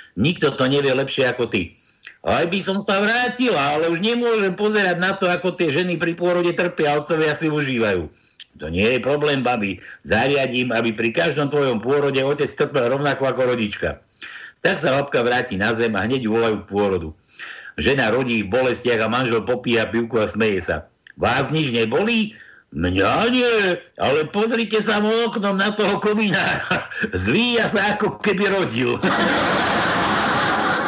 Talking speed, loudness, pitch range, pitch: 160 wpm, -19 LUFS, 125-200 Hz, 155 Hz